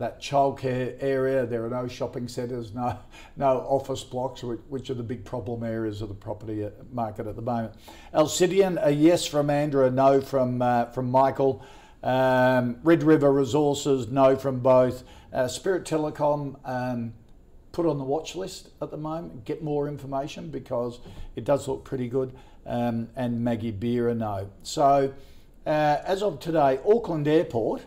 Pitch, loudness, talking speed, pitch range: 130 Hz, -25 LUFS, 165 wpm, 120-145 Hz